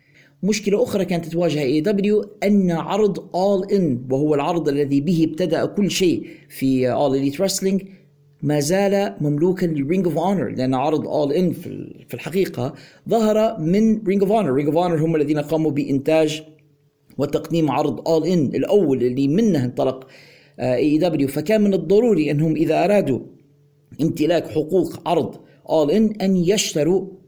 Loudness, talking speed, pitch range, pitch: -20 LUFS, 150 wpm, 145-190 Hz, 160 Hz